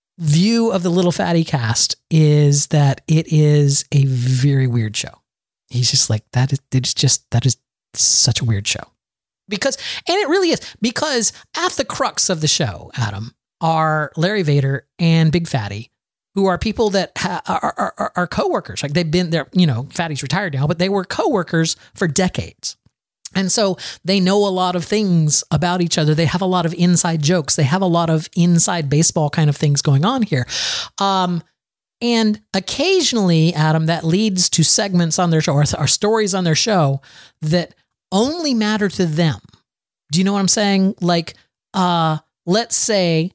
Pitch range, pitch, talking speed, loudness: 145-190 Hz, 170 Hz, 185 wpm, -17 LUFS